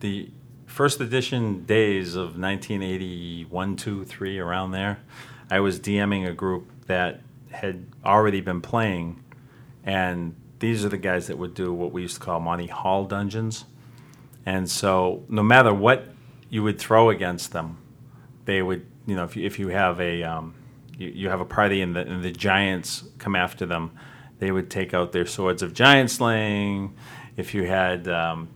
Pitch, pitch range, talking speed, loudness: 95 Hz, 90-115 Hz, 175 wpm, -24 LUFS